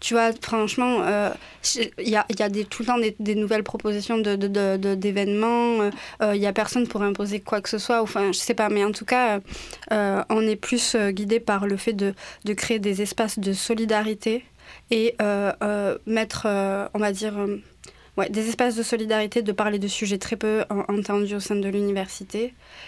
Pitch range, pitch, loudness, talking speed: 205-225 Hz, 210 Hz, -24 LUFS, 220 wpm